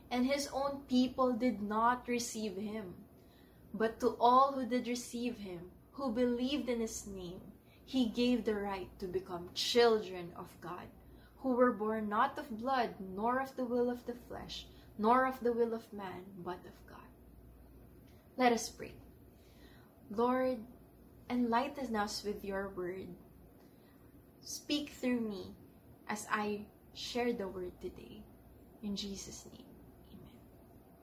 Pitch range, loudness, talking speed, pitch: 205-250 Hz, -36 LUFS, 140 wpm, 235 Hz